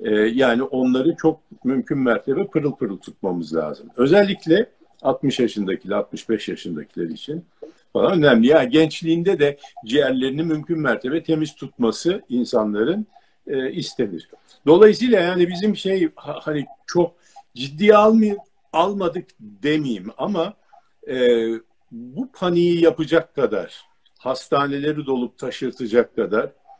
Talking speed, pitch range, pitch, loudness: 105 wpm, 135-210 Hz, 165 Hz, -20 LUFS